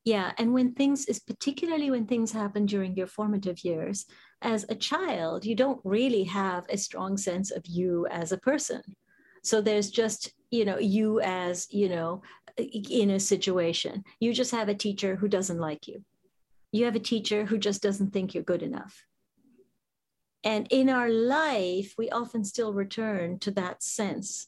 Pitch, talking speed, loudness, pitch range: 210 Hz, 175 wpm, -29 LUFS, 190-230 Hz